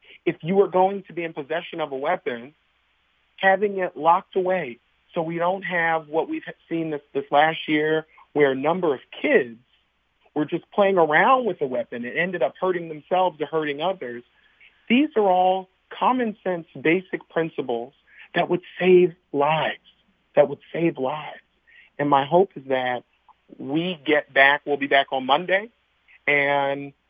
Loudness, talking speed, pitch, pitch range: -22 LUFS, 165 wpm, 160 Hz, 145-185 Hz